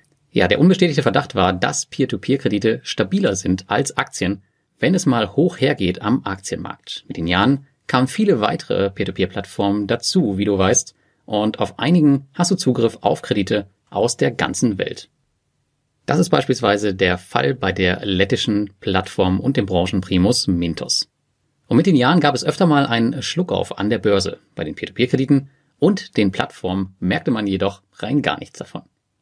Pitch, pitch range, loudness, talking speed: 105 Hz, 100-140 Hz, -19 LUFS, 160 wpm